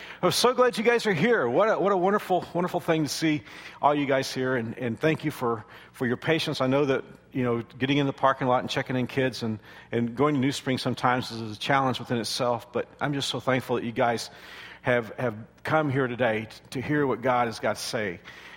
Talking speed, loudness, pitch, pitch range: 240 wpm, -26 LUFS, 130 Hz, 120-150 Hz